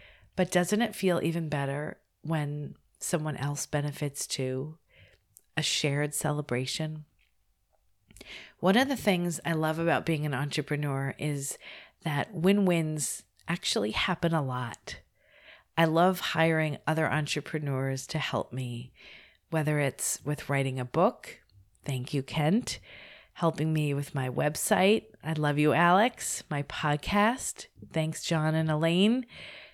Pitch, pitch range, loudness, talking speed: 155 Hz, 140-170 Hz, -29 LUFS, 130 wpm